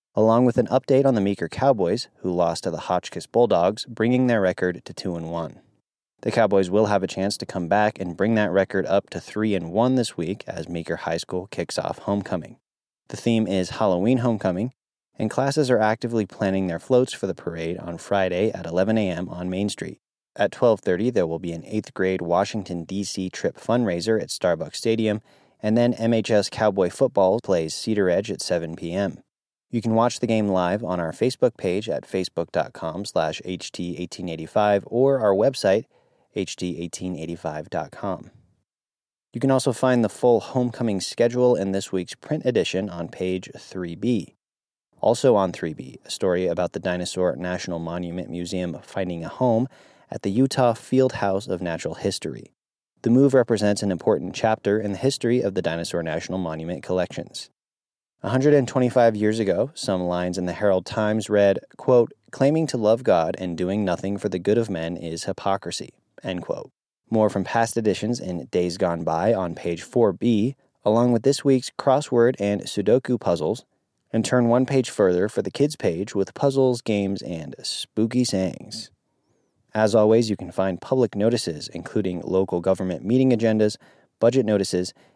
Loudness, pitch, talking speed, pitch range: -23 LUFS, 100 Hz, 170 wpm, 90-120 Hz